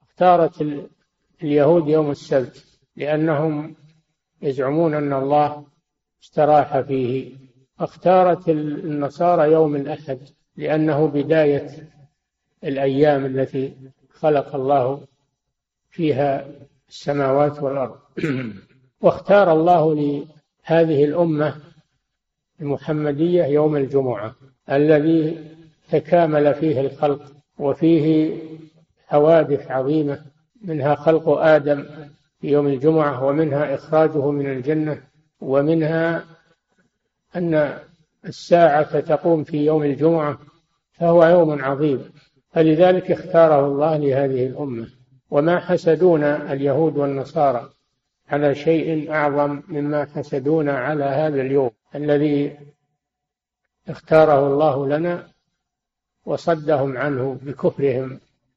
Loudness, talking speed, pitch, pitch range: -19 LUFS, 85 wpm, 150 Hz, 140-160 Hz